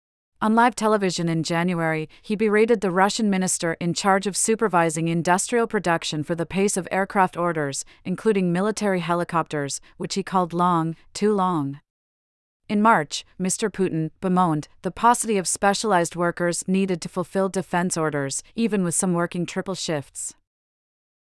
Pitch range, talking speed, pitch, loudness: 165-200 Hz, 145 wpm, 180 Hz, -23 LUFS